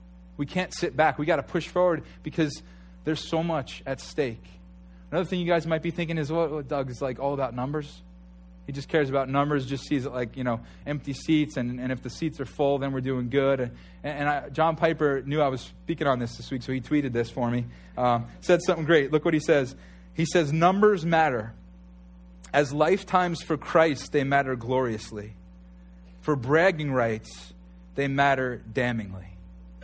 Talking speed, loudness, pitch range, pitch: 200 wpm, -26 LUFS, 110-155 Hz, 140 Hz